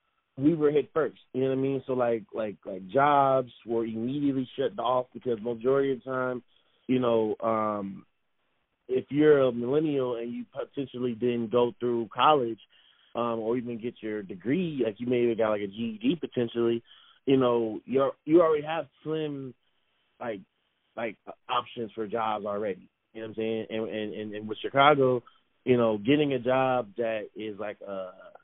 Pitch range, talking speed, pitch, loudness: 110-135 Hz, 180 wpm, 120 Hz, -28 LUFS